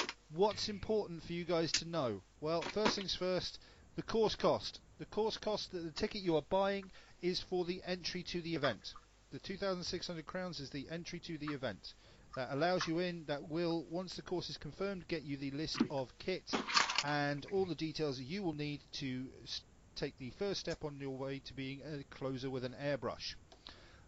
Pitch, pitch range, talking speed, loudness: 160 Hz, 135-180 Hz, 195 wpm, -39 LUFS